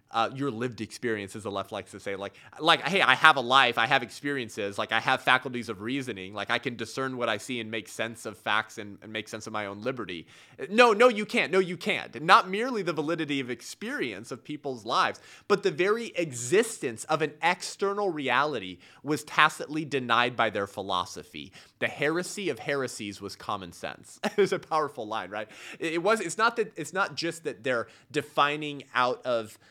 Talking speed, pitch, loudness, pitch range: 210 wpm, 135 Hz, -27 LUFS, 115-160 Hz